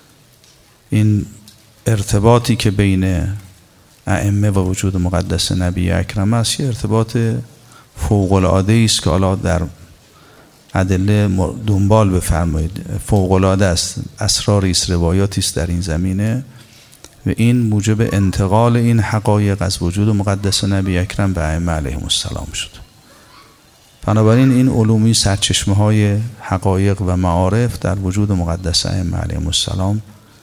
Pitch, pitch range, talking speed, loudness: 100 Hz, 90-110 Hz, 120 wpm, -16 LUFS